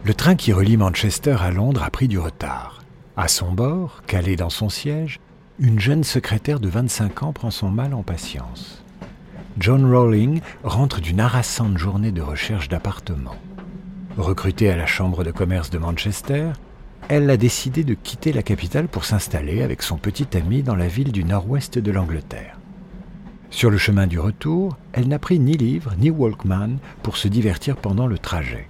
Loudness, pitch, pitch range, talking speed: -20 LUFS, 110 Hz, 95-140 Hz, 175 wpm